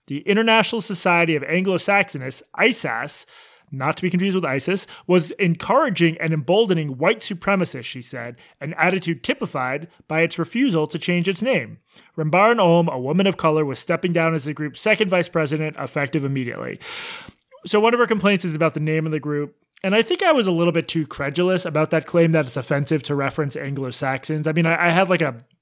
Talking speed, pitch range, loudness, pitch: 200 wpm, 150-190 Hz, -20 LUFS, 165 Hz